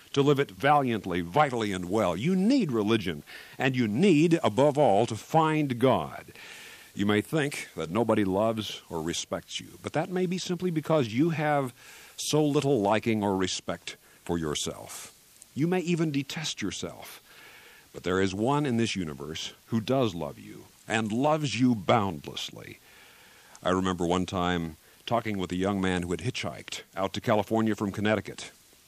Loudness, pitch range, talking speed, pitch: -28 LUFS, 95-145 Hz, 165 wpm, 115 Hz